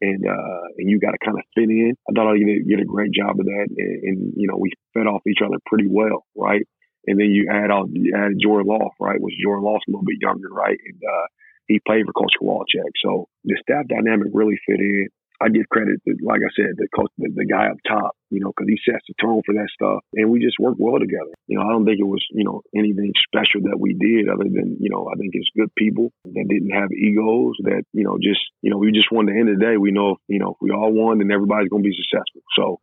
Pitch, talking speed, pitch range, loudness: 105 Hz, 270 wpm, 100-110 Hz, -19 LUFS